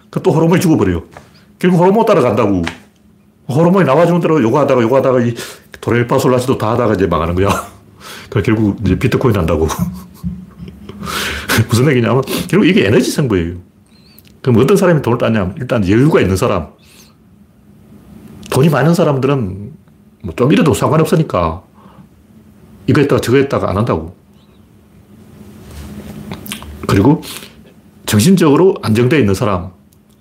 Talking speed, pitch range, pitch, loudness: 315 characters per minute, 100-145 Hz, 120 Hz, -13 LUFS